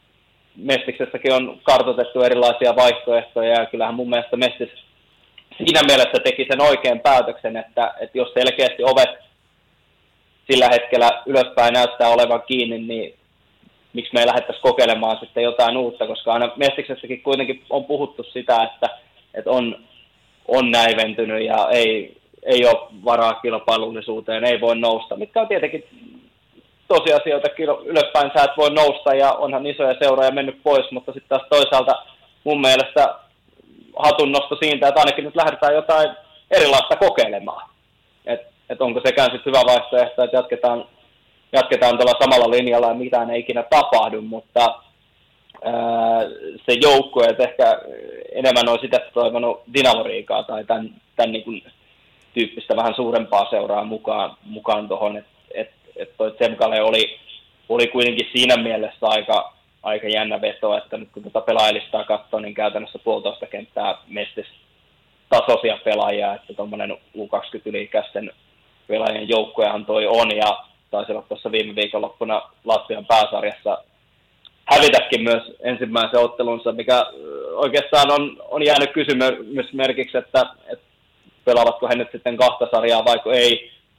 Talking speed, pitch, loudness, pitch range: 135 wpm, 125 Hz, -18 LUFS, 115-145 Hz